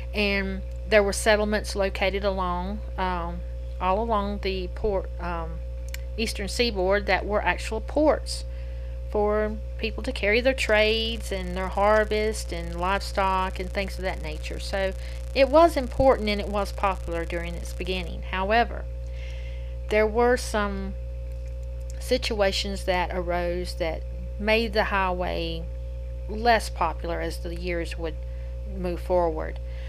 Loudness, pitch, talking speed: -26 LUFS, 175 Hz, 130 wpm